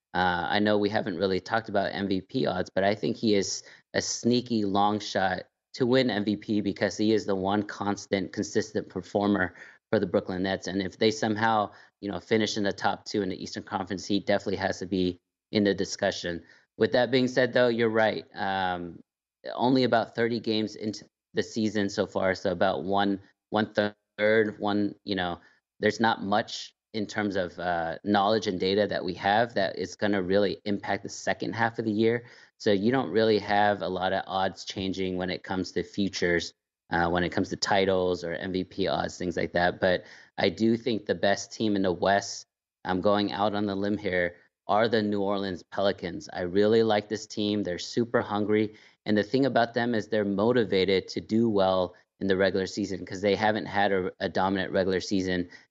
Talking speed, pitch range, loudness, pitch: 200 wpm, 95-110 Hz, -27 LUFS, 100 Hz